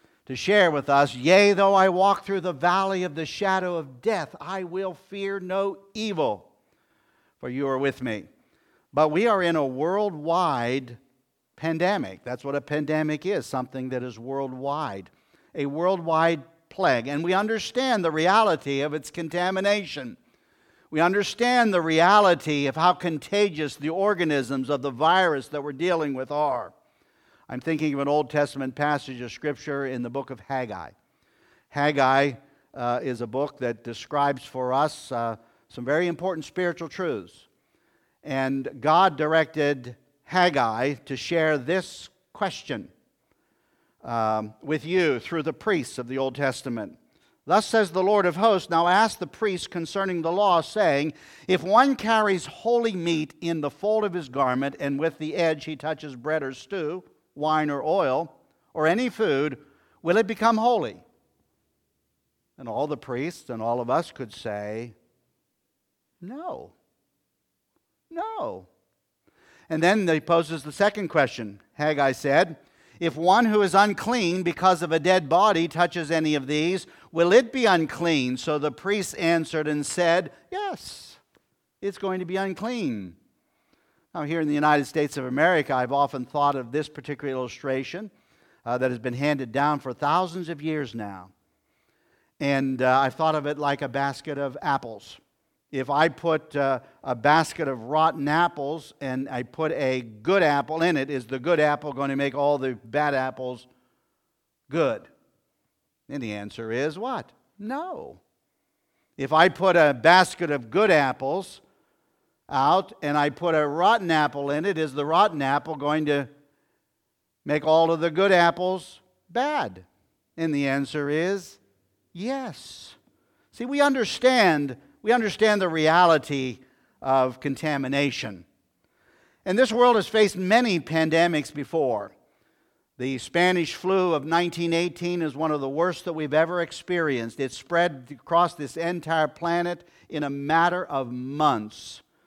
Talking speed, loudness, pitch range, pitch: 150 wpm, -24 LUFS, 135-180 Hz, 155 Hz